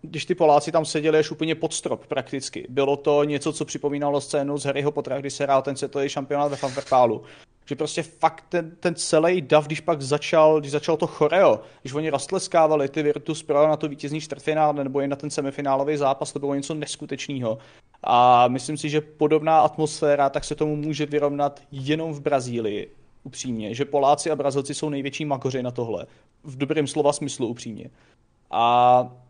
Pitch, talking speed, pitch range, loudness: 145 Hz, 185 wpm, 140-155 Hz, -23 LUFS